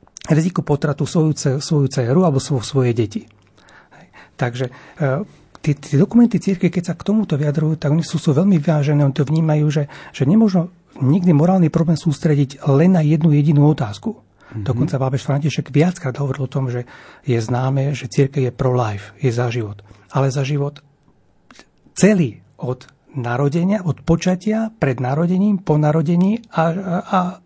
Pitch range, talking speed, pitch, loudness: 135-170 Hz, 155 wpm, 150 Hz, -18 LUFS